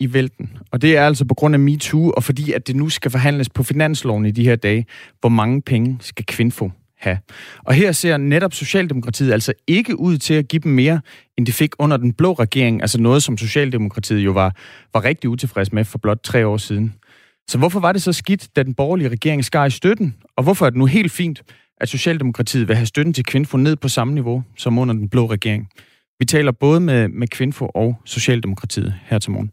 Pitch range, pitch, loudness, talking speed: 115-150 Hz, 130 Hz, -17 LUFS, 225 wpm